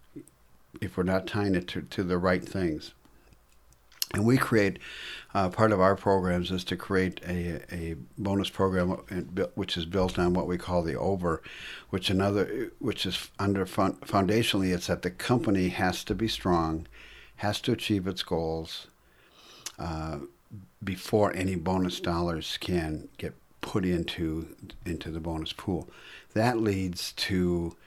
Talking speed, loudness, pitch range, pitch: 150 wpm, -29 LUFS, 85-100 Hz, 90 Hz